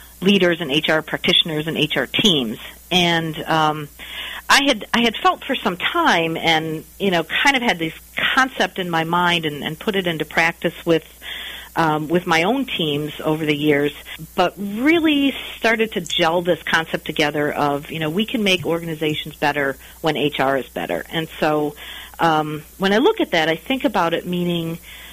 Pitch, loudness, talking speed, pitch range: 165 Hz, -19 LUFS, 180 wpm, 155-195 Hz